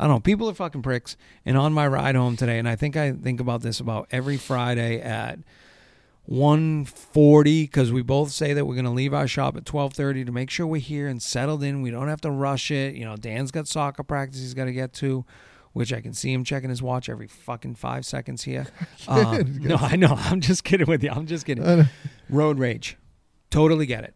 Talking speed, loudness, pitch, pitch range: 230 wpm, -23 LUFS, 140 Hz, 125-150 Hz